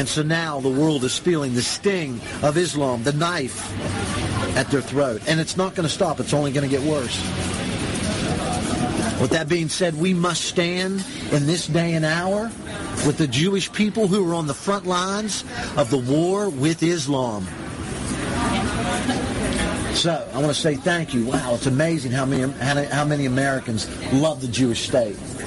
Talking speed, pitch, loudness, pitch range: 175 wpm, 145 Hz, -22 LUFS, 125-170 Hz